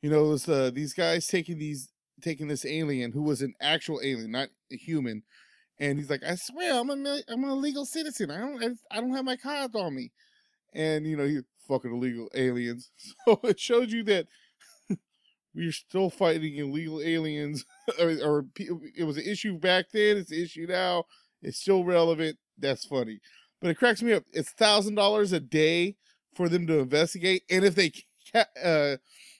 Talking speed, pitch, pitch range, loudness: 190 wpm, 170 Hz, 150-210 Hz, -28 LUFS